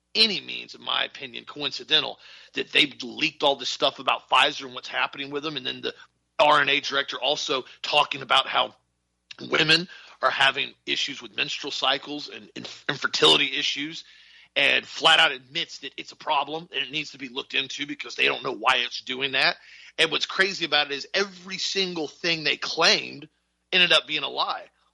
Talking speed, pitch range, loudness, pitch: 190 wpm, 140-170 Hz, -23 LUFS, 150 Hz